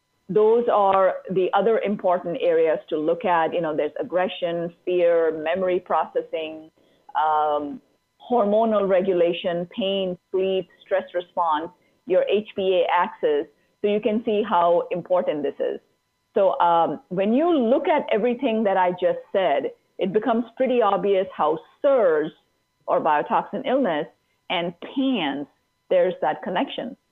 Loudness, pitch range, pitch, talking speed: -22 LUFS, 175-240 Hz, 190 Hz, 130 wpm